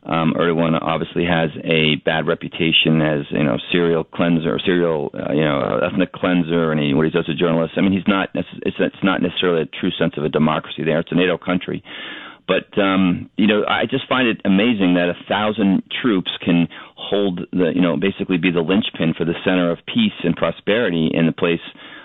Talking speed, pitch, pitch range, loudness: 220 wpm, 85 Hz, 80-95 Hz, -18 LUFS